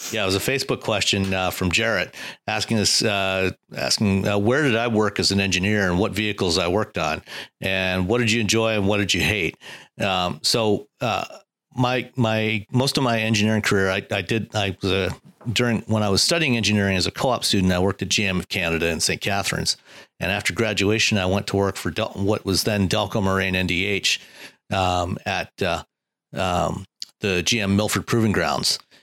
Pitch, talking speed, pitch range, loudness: 100 Hz, 200 wpm, 95-110 Hz, -21 LUFS